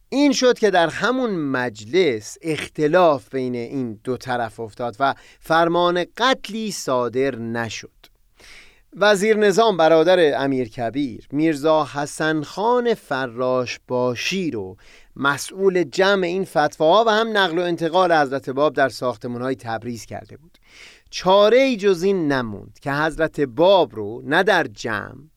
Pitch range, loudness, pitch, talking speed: 125-190 Hz, -20 LUFS, 150 Hz, 135 wpm